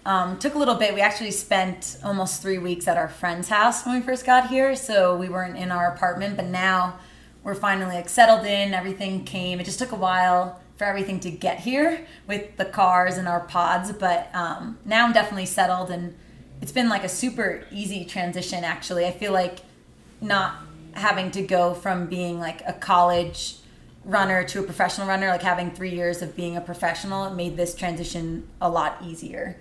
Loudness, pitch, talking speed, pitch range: -23 LUFS, 185 Hz, 200 wpm, 175-200 Hz